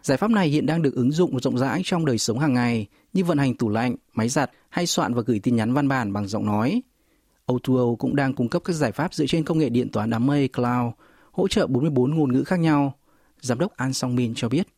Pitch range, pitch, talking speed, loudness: 120-155 Hz, 130 Hz, 260 wpm, -23 LUFS